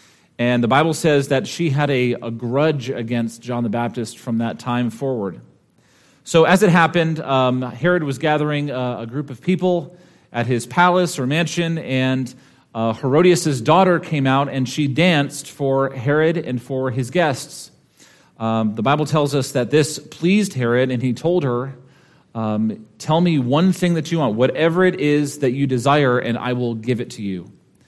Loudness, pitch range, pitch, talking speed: -19 LUFS, 125-160 Hz, 135 Hz, 185 wpm